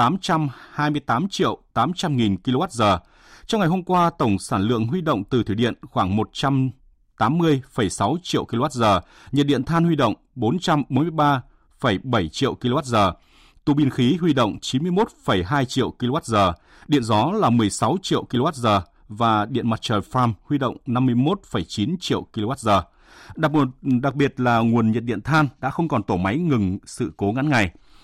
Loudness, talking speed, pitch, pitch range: -21 LUFS, 150 wpm, 130 Hz, 110-150 Hz